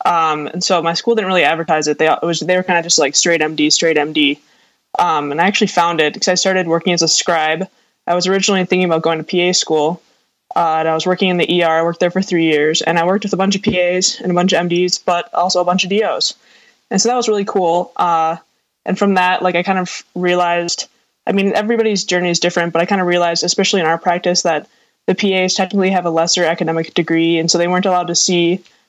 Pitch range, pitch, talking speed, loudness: 165-185 Hz, 175 Hz, 255 wpm, -15 LUFS